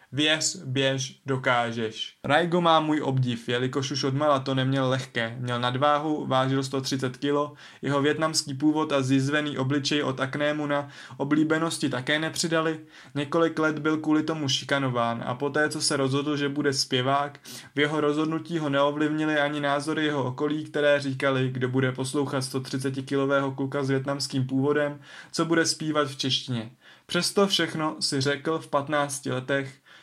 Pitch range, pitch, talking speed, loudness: 135-150 Hz, 145 Hz, 150 wpm, -26 LUFS